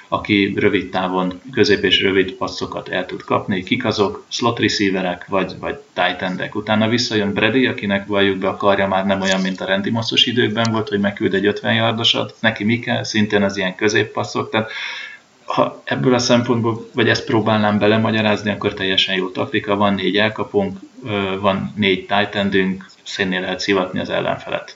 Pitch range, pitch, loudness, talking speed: 95-110 Hz, 100 Hz, -18 LUFS, 175 wpm